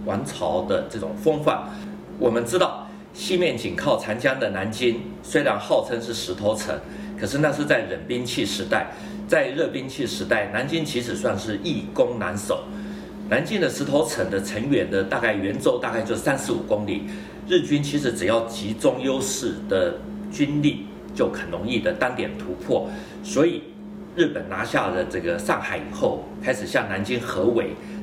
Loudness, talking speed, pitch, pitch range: -24 LUFS, 255 characters per minute, 120 Hz, 105-155 Hz